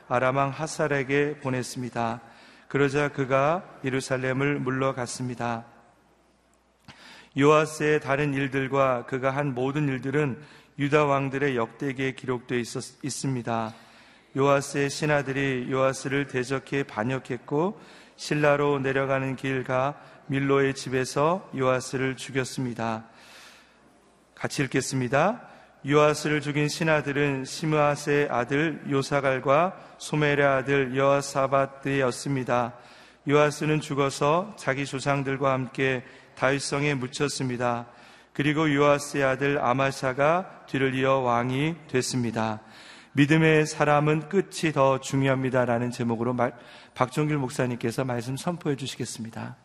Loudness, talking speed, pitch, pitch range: -26 LUFS, 285 characters per minute, 135 Hz, 130-145 Hz